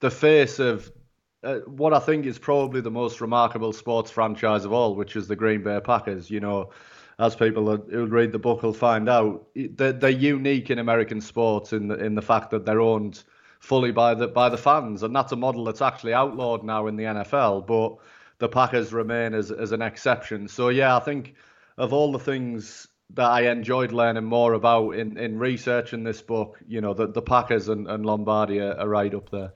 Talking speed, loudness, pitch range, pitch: 215 wpm, -23 LUFS, 110-125 Hz, 115 Hz